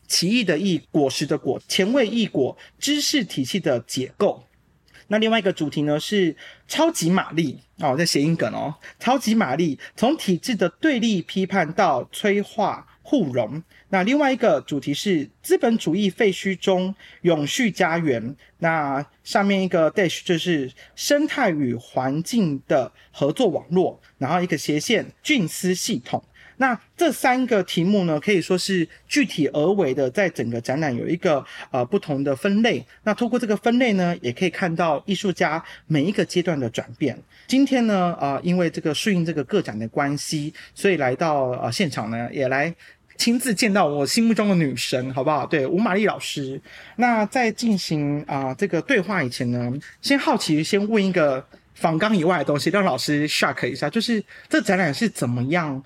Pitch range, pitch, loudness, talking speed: 145-215 Hz, 180 Hz, -22 LUFS, 270 characters per minute